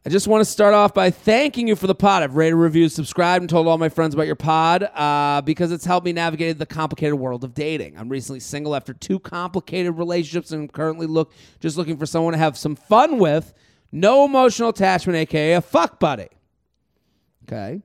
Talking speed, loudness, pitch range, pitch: 210 wpm, -19 LUFS, 155-180 Hz, 165 Hz